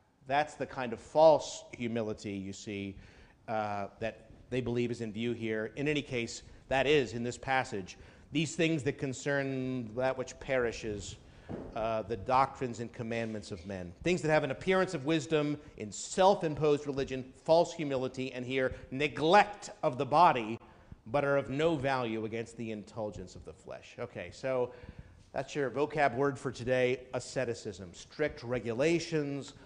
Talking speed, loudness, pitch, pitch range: 160 wpm, -32 LUFS, 130 Hz, 110-145 Hz